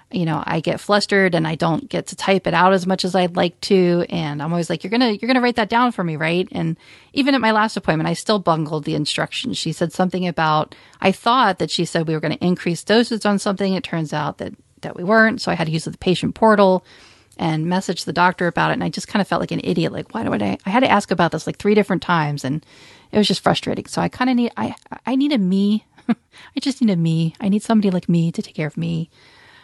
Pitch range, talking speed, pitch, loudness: 165-210 Hz, 275 wpm, 185 Hz, -19 LUFS